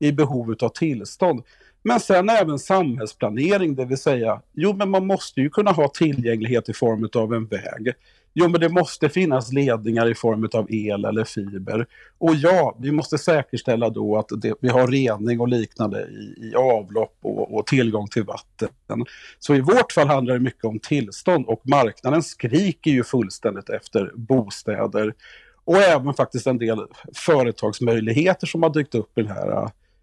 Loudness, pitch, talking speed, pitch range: -21 LUFS, 125 Hz, 170 wpm, 110-155 Hz